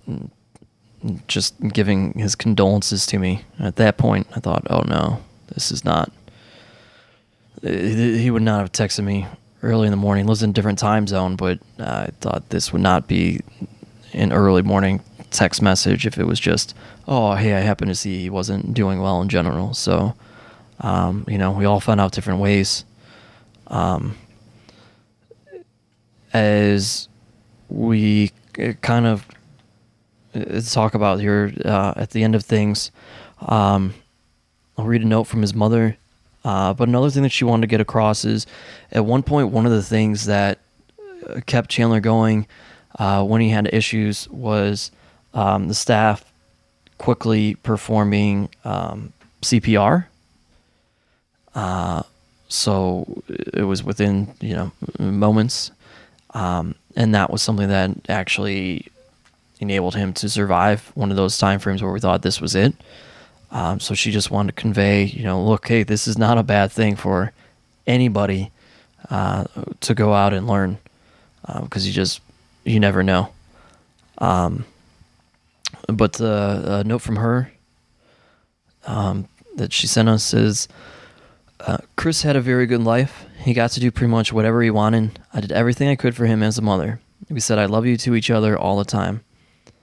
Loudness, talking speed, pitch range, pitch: -19 LUFS, 160 wpm, 100-115 Hz, 105 Hz